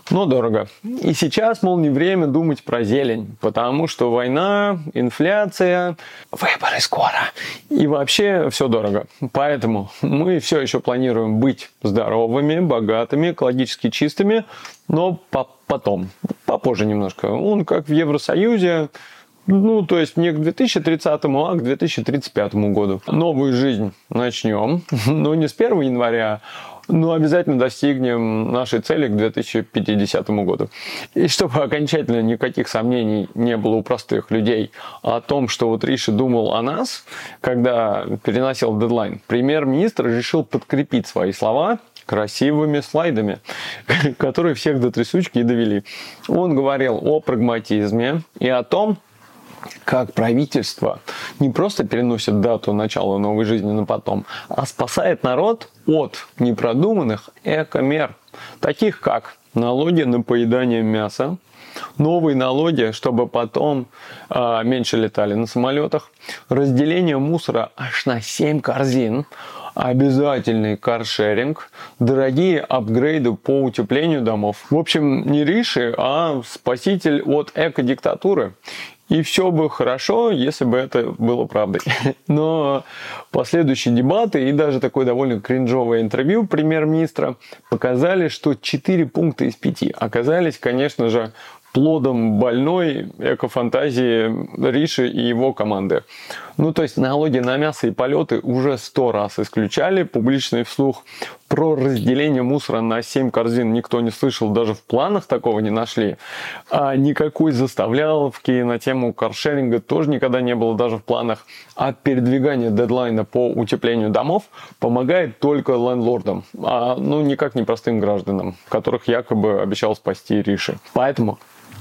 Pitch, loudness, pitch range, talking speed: 130 Hz, -19 LUFS, 115-155 Hz, 125 wpm